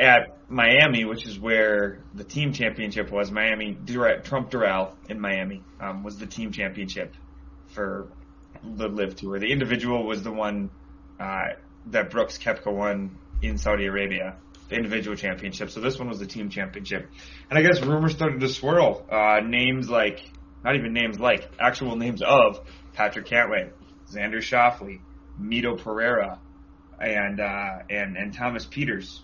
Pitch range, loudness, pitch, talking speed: 95-115 Hz, -24 LUFS, 105 Hz, 155 wpm